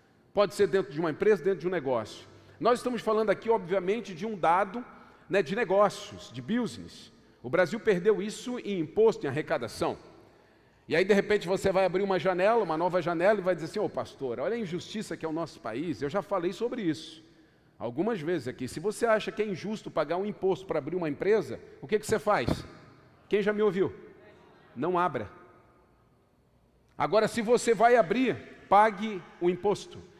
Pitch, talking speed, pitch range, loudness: 195 Hz, 195 wpm, 165-215 Hz, -29 LUFS